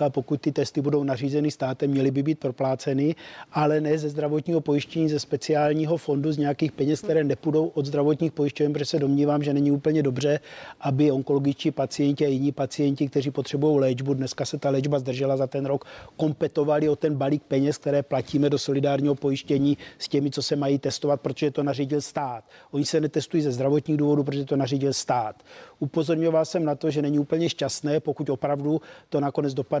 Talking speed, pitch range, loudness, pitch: 190 wpm, 140-150 Hz, -25 LUFS, 145 Hz